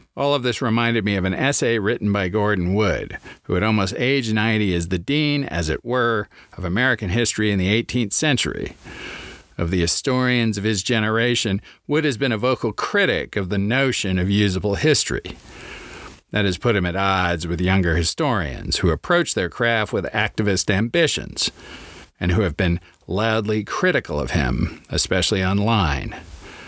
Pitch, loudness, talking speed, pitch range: 105 Hz, -20 LUFS, 165 wpm, 95-120 Hz